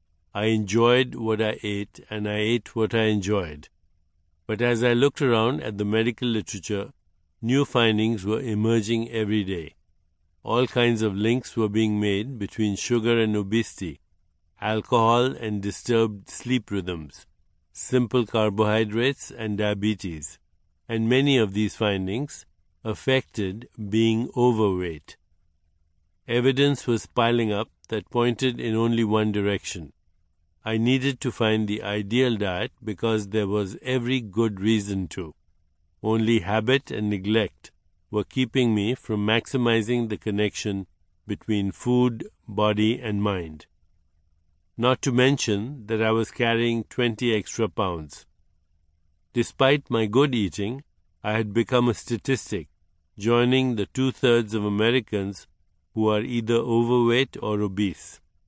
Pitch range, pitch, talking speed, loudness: 95-120 Hz, 110 Hz, 125 wpm, -24 LUFS